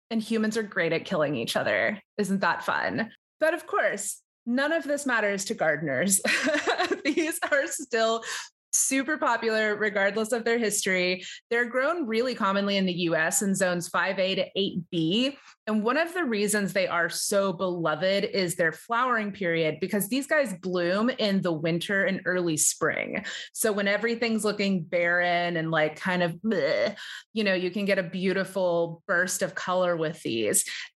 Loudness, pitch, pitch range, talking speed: -26 LUFS, 200 Hz, 180-235 Hz, 165 wpm